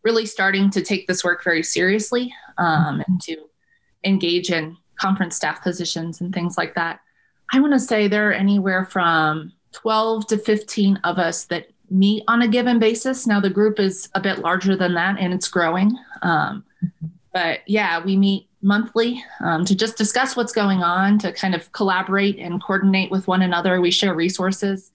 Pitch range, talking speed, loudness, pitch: 175-215 Hz, 185 wpm, -20 LUFS, 195 Hz